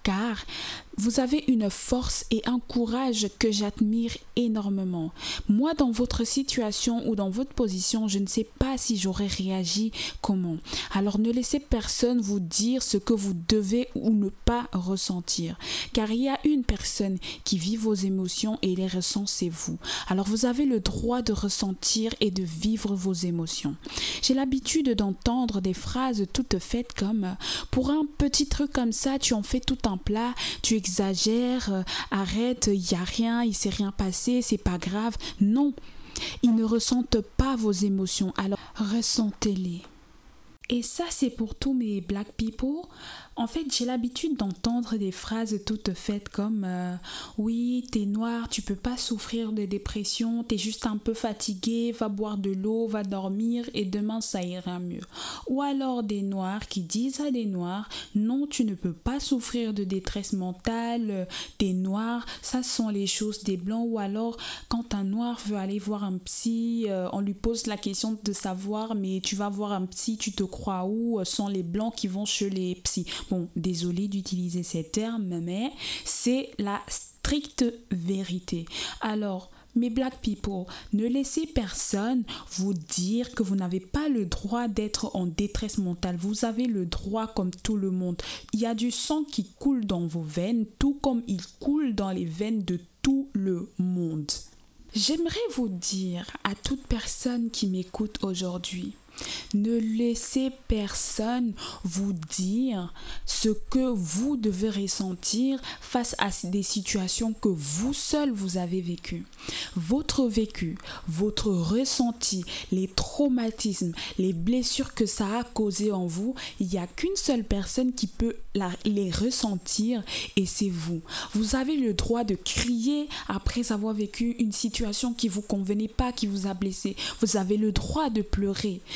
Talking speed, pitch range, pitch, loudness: 170 wpm, 195-240 Hz, 215 Hz, -27 LUFS